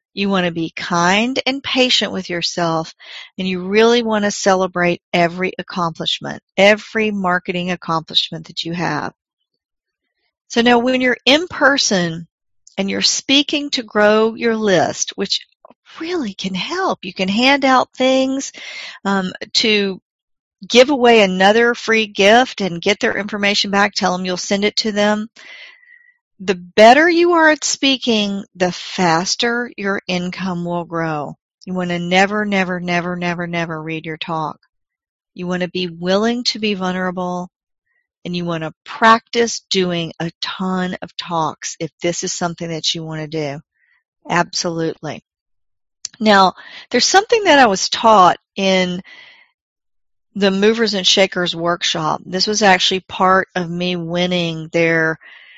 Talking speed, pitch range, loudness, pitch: 145 wpm, 175-230 Hz, -16 LUFS, 190 Hz